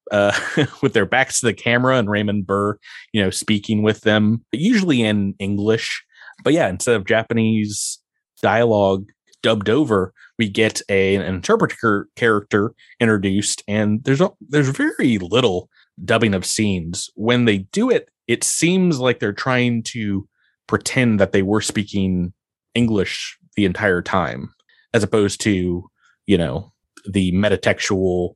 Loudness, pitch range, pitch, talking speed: -19 LUFS, 100-115 Hz, 105 Hz, 145 wpm